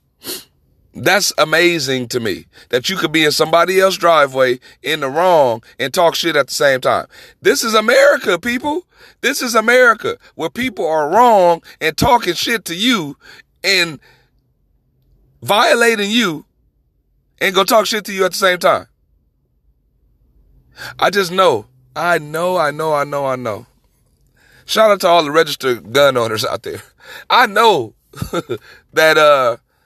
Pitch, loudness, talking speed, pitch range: 170 Hz, -14 LUFS, 155 wpm, 145-215 Hz